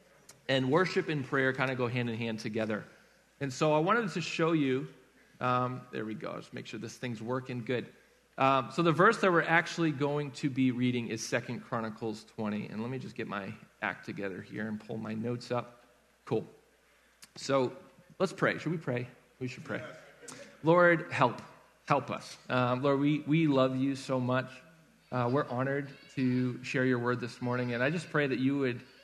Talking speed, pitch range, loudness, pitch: 200 wpm, 120-150 Hz, -31 LUFS, 130 Hz